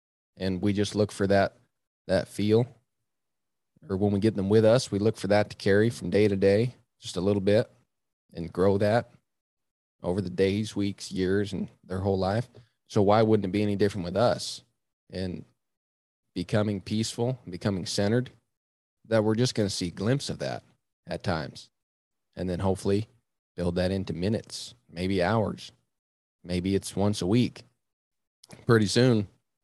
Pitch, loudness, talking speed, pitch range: 105 Hz, -27 LUFS, 170 wpm, 95-110 Hz